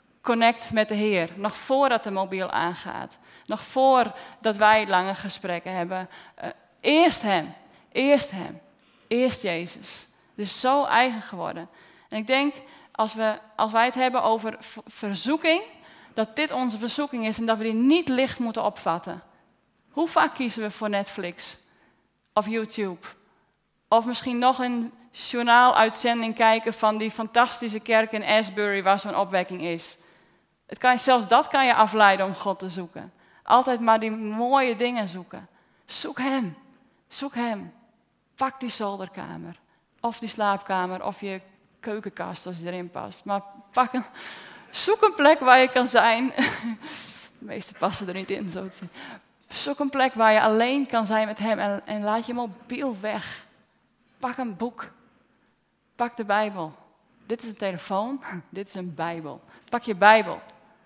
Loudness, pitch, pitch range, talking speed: -24 LUFS, 220 Hz, 200-250 Hz, 160 wpm